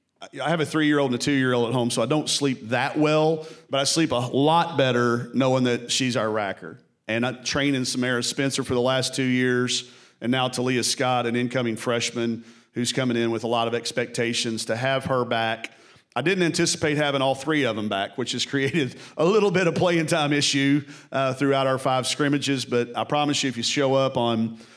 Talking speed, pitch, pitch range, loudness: 215 wpm, 130 Hz, 120-145 Hz, -23 LUFS